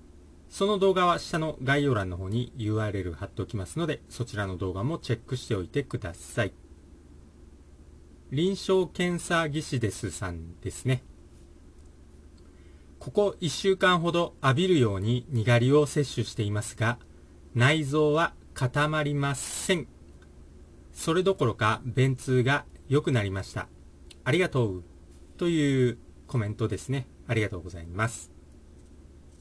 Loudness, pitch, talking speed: -28 LUFS, 110 Hz, 270 characters per minute